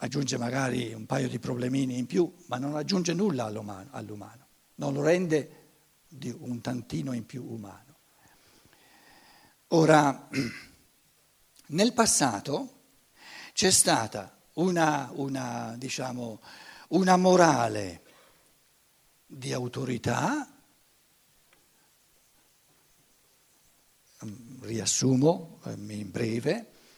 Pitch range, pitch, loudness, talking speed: 115-160 Hz, 130 Hz, -27 LUFS, 80 wpm